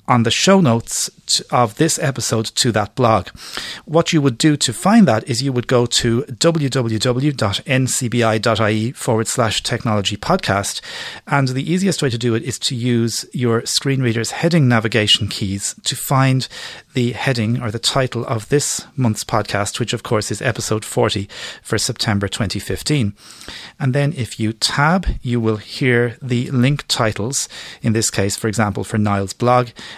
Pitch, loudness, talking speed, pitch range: 120 Hz, -17 LUFS, 165 wpm, 110-135 Hz